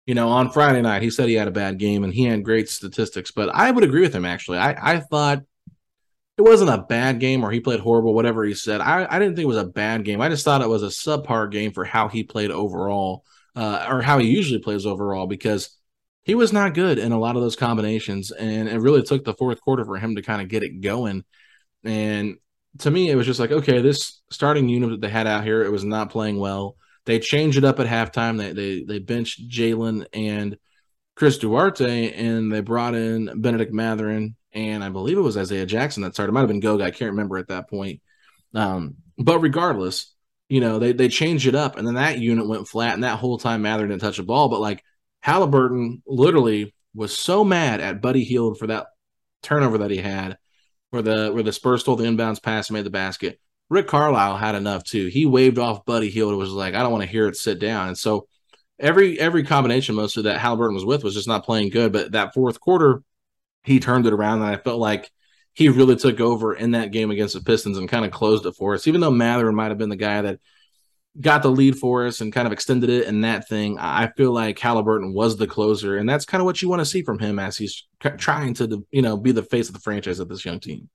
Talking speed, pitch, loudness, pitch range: 245 wpm, 115 Hz, -21 LUFS, 105-125 Hz